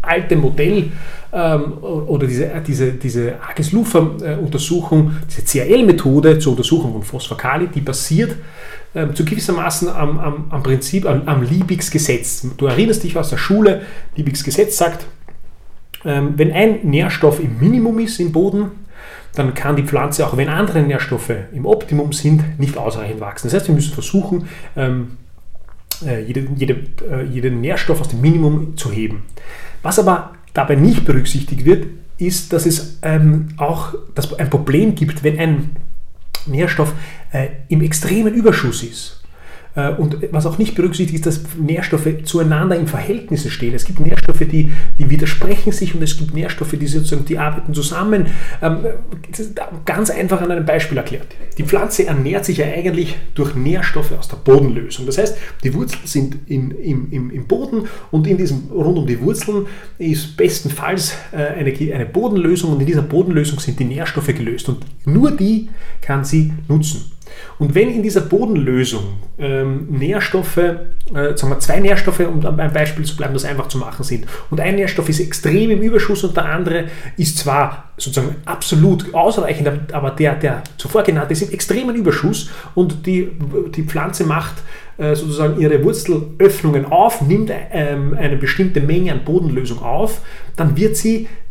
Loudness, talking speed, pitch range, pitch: -17 LUFS, 160 wpm, 140-175 Hz, 155 Hz